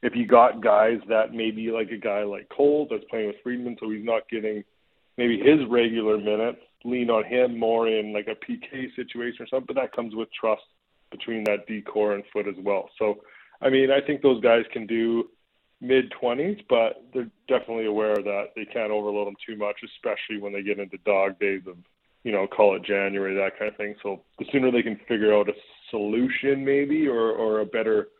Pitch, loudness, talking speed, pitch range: 115 Hz, -25 LUFS, 210 wpm, 105-125 Hz